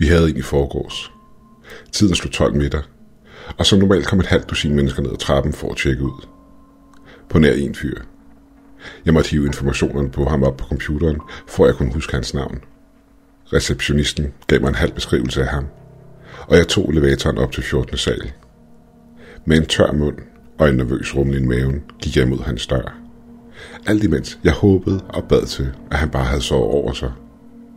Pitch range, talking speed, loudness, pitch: 70-80 Hz, 190 wpm, -18 LUFS, 75 Hz